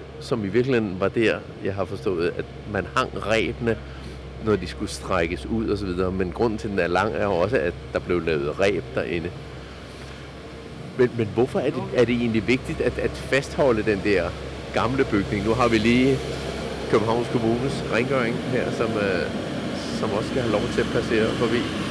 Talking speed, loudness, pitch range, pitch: 190 wpm, -24 LUFS, 80-120 Hz, 110 Hz